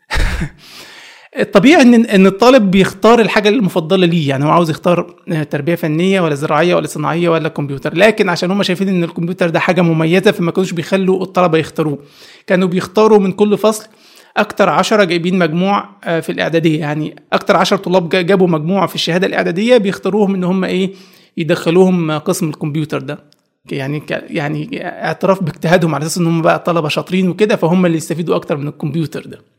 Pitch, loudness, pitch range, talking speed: 180 Hz, -13 LUFS, 165-195 Hz, 165 wpm